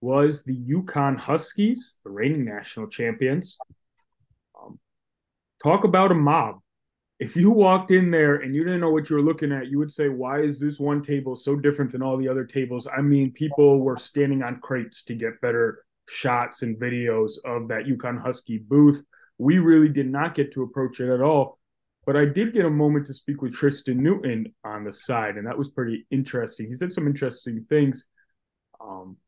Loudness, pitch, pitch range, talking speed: -23 LUFS, 140 Hz, 125-150 Hz, 195 wpm